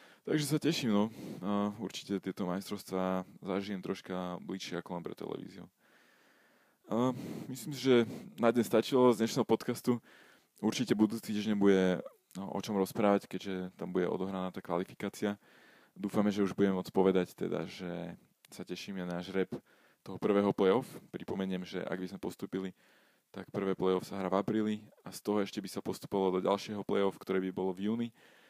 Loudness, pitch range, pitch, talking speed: -34 LUFS, 95-105 Hz, 100 Hz, 175 wpm